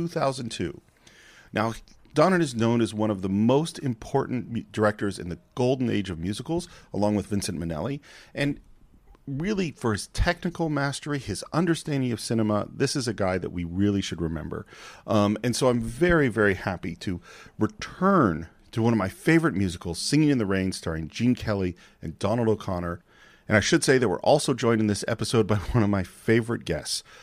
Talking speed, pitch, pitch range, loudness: 185 wpm, 115 Hz, 100-140 Hz, -26 LUFS